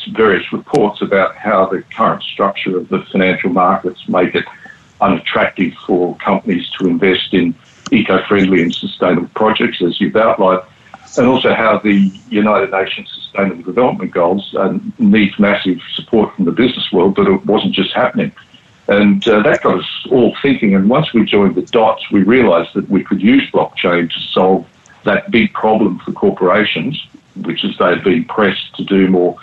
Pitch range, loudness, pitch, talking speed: 95-105 Hz, -13 LUFS, 95 Hz, 170 wpm